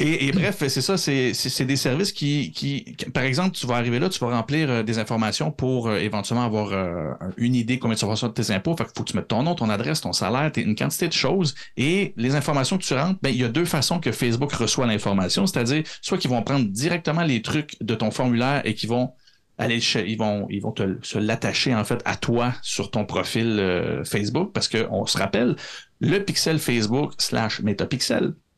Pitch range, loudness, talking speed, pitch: 110-145 Hz, -23 LUFS, 235 wpm, 125 Hz